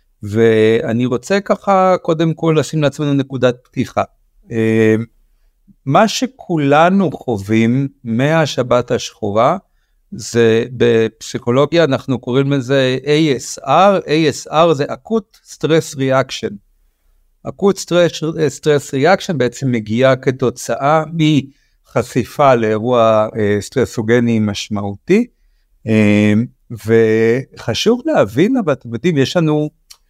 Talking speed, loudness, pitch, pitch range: 85 wpm, -15 LUFS, 130 Hz, 115-155 Hz